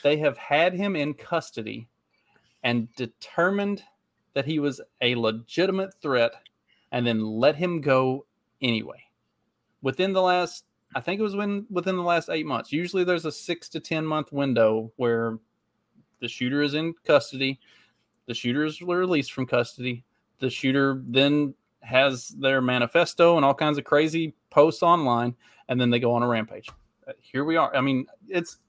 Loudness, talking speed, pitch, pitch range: -25 LUFS, 165 wpm, 140 Hz, 125-170 Hz